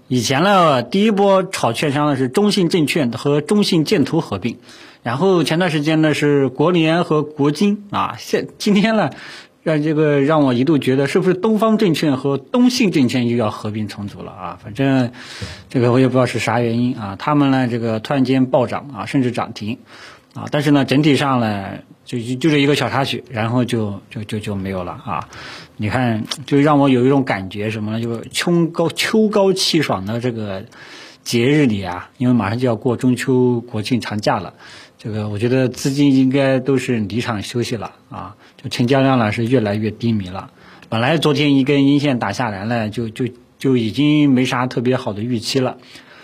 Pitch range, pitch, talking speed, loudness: 115-150 Hz, 130 Hz, 285 characters per minute, -17 LUFS